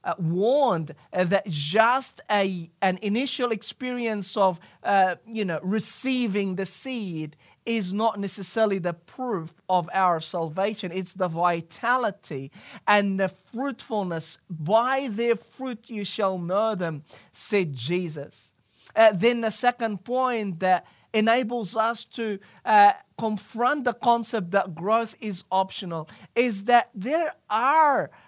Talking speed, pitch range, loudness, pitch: 125 wpm, 180-230 Hz, -25 LUFS, 205 Hz